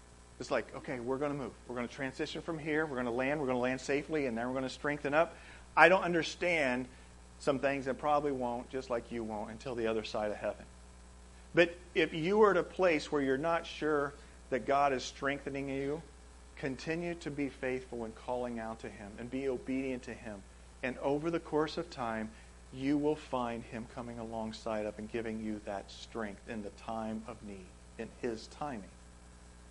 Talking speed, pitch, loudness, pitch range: 210 wpm, 125 Hz, -35 LUFS, 110-145 Hz